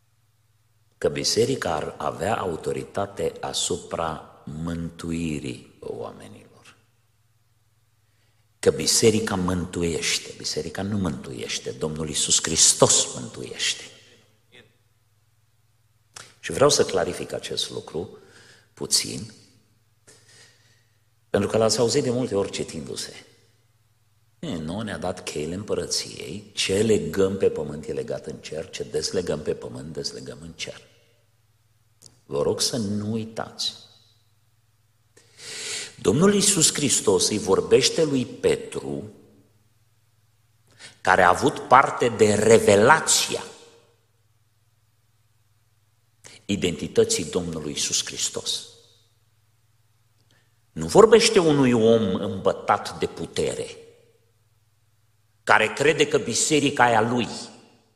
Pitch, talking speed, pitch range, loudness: 115 Hz, 90 wpm, 110-120 Hz, -22 LUFS